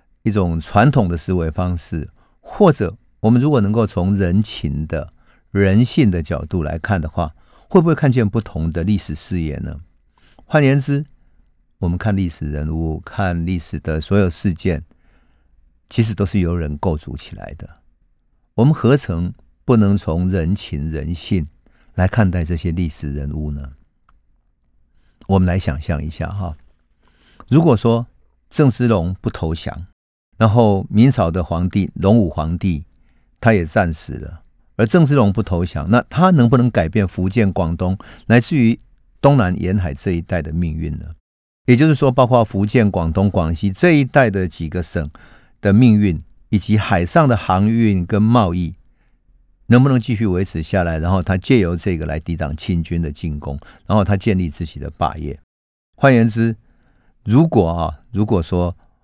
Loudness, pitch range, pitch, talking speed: -17 LUFS, 80-110 Hz, 90 Hz, 235 characters per minute